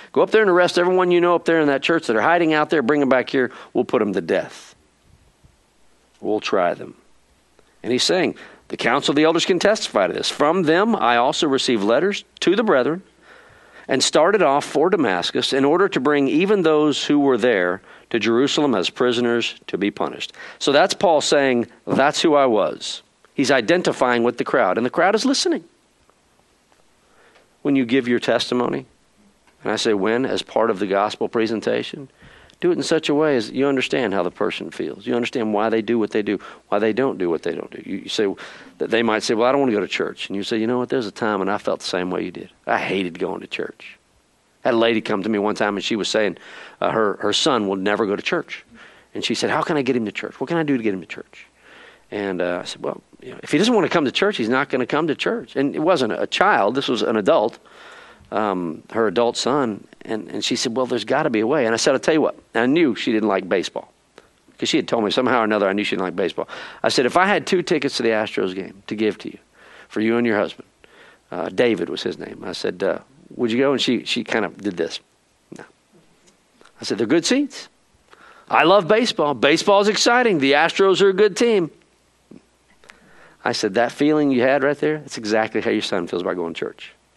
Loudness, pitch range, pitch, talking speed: -20 LUFS, 110-160 Hz, 130 Hz, 245 wpm